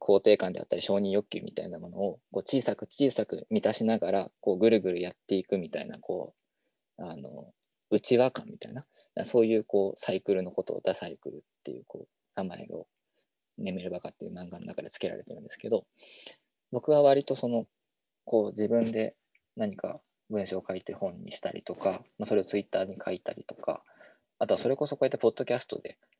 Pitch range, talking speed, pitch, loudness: 100-120 Hz, 400 characters per minute, 110 Hz, -30 LUFS